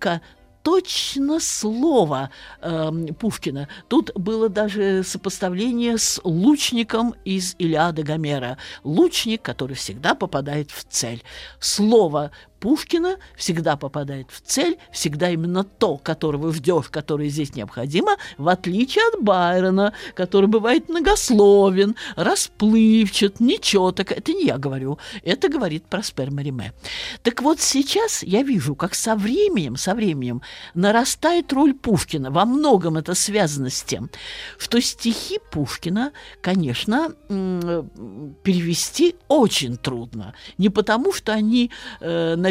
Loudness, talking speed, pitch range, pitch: -20 LUFS, 115 wpm, 155-235 Hz, 195 Hz